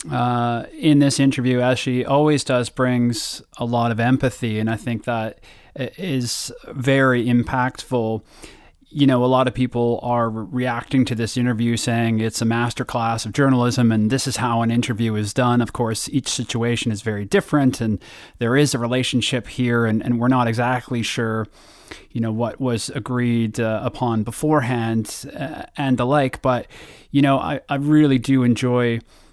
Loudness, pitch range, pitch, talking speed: -20 LUFS, 115-130 Hz, 120 Hz, 175 wpm